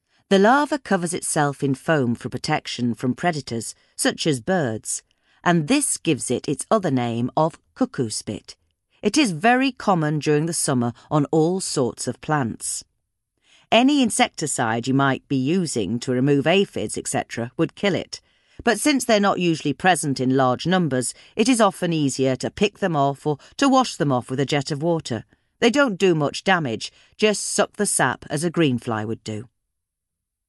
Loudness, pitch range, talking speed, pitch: -21 LUFS, 125-195 Hz, 175 wpm, 150 Hz